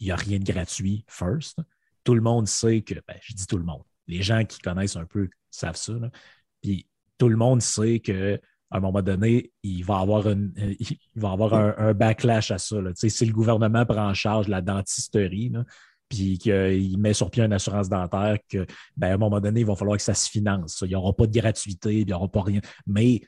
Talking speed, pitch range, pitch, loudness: 250 wpm, 100-115 Hz, 105 Hz, -24 LUFS